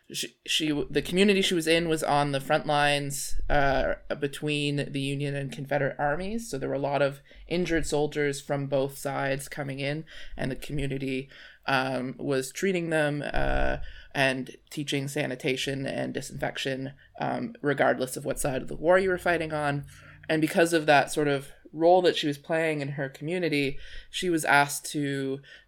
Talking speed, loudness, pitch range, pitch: 175 wpm, -27 LUFS, 135-155 Hz, 145 Hz